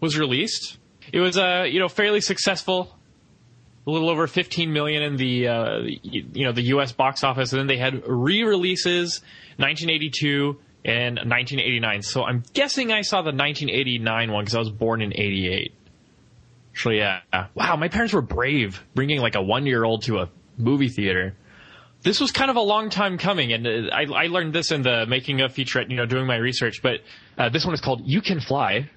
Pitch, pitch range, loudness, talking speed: 135 Hz, 120-170 Hz, -22 LUFS, 210 wpm